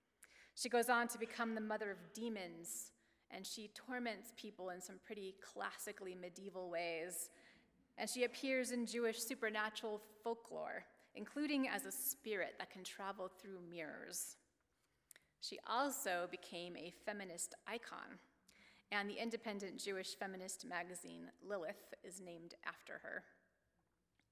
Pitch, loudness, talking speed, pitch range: 200 Hz, -45 LUFS, 130 wpm, 180-230 Hz